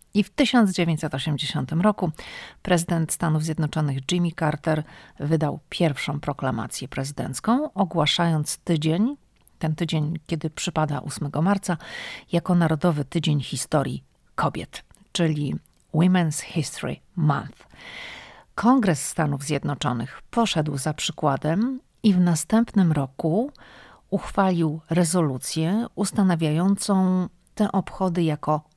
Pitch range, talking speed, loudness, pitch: 150-185 Hz, 95 wpm, -24 LUFS, 165 Hz